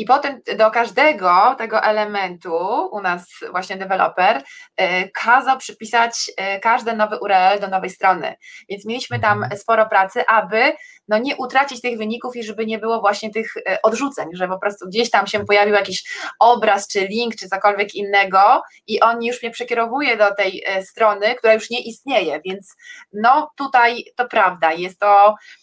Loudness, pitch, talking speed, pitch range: -18 LUFS, 220 Hz, 160 wpm, 195-235 Hz